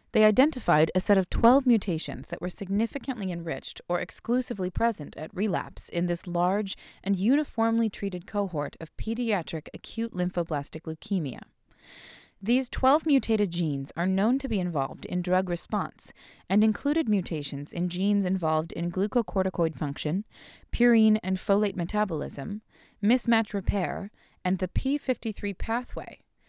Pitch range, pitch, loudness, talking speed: 175-225 Hz, 195 Hz, -27 LUFS, 135 wpm